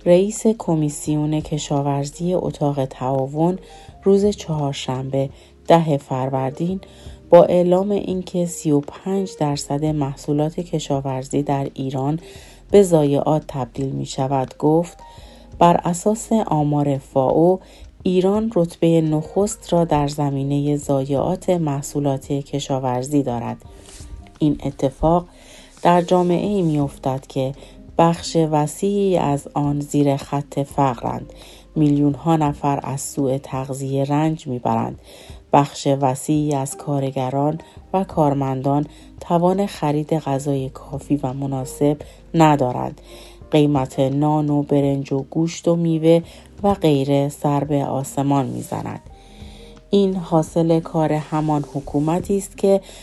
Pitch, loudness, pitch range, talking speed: 145 Hz, -20 LUFS, 140-170 Hz, 105 wpm